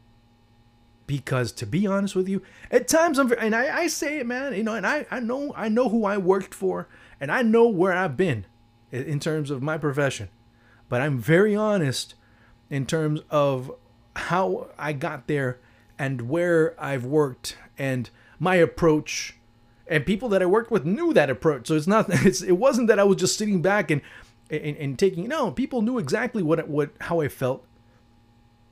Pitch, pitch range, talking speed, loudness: 155 Hz, 125-200 Hz, 190 wpm, -24 LUFS